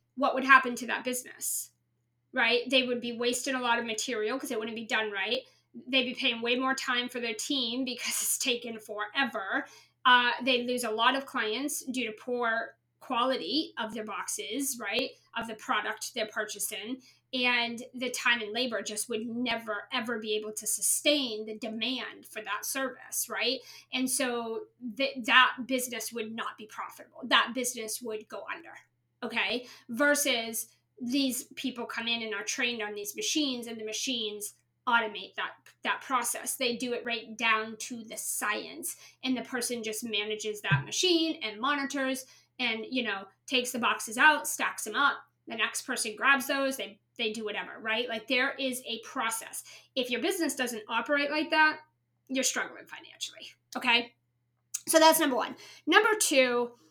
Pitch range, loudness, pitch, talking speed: 220-260 Hz, -29 LUFS, 240 Hz, 175 wpm